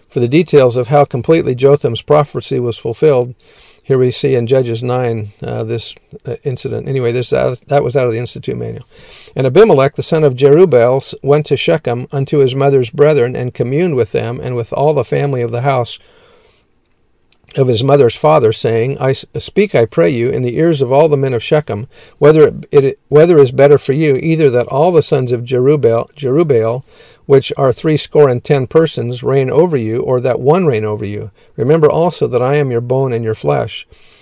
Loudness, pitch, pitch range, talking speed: -12 LUFS, 135 Hz, 120-145 Hz, 205 wpm